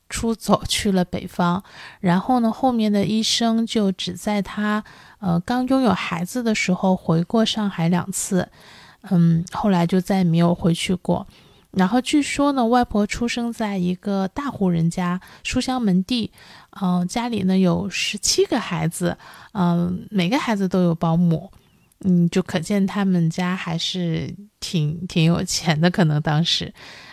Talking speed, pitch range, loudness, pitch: 230 characters per minute, 175-220 Hz, -21 LUFS, 185 Hz